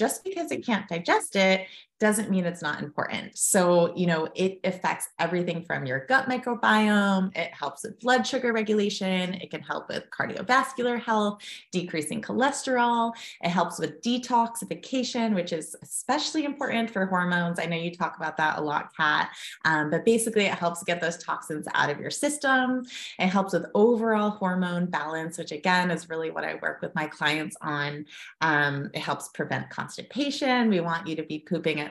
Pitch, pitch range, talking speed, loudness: 185 Hz, 165-230 Hz, 180 wpm, -26 LUFS